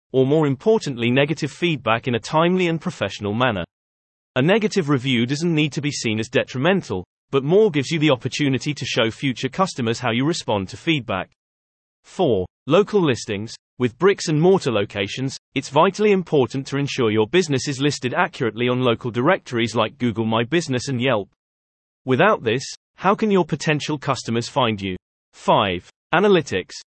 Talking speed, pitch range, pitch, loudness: 165 wpm, 115-160 Hz, 135 Hz, -20 LUFS